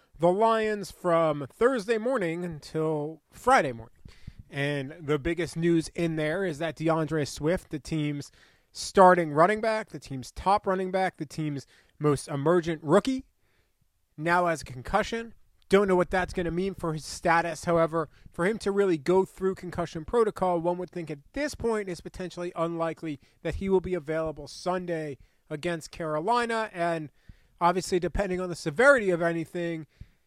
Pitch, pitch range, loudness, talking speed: 170 Hz, 155-185 Hz, -27 LUFS, 160 wpm